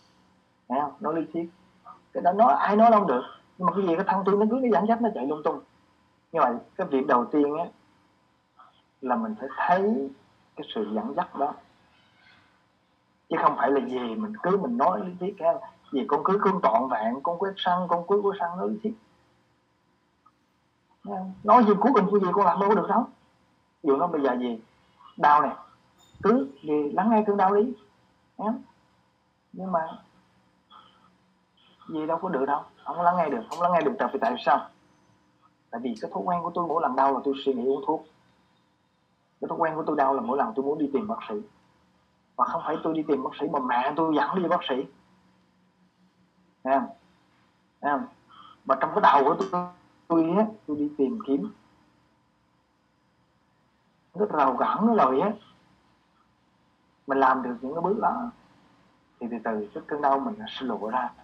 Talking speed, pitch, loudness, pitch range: 200 wpm, 160 Hz, -25 LUFS, 135-195 Hz